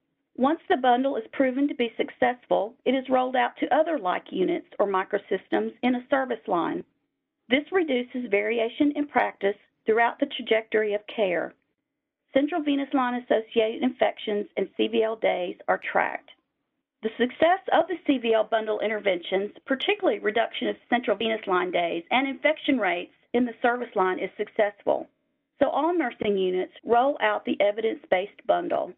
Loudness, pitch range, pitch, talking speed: -26 LUFS, 215-290 Hz, 245 Hz, 155 wpm